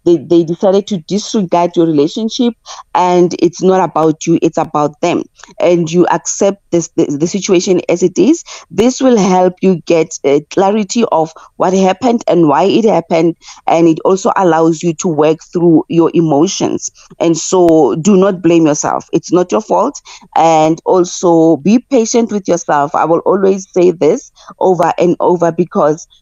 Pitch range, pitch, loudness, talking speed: 165-195 Hz, 175 Hz, -11 LUFS, 170 wpm